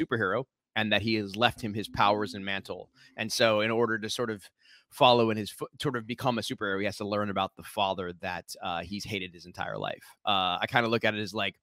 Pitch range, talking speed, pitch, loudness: 100-115 Hz, 260 wpm, 105 Hz, -29 LUFS